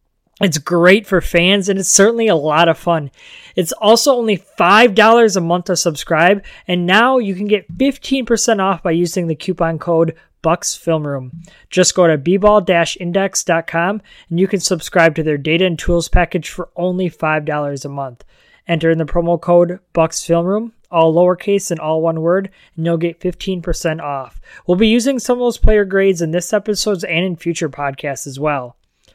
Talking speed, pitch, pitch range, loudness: 175 wpm, 175 Hz, 165-200 Hz, -15 LUFS